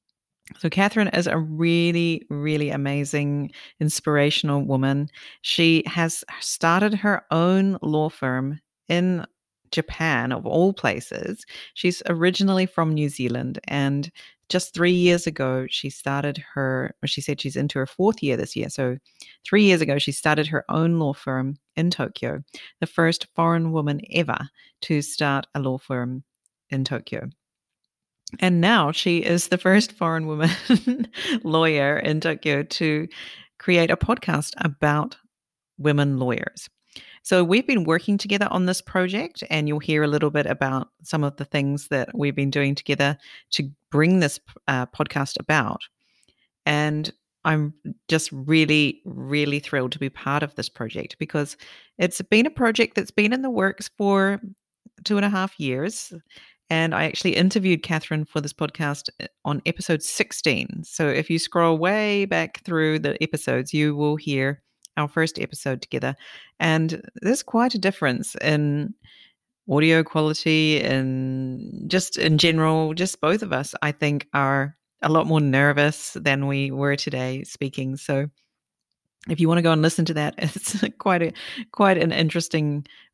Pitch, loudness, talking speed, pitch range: 155 Hz, -22 LUFS, 155 wpm, 145-180 Hz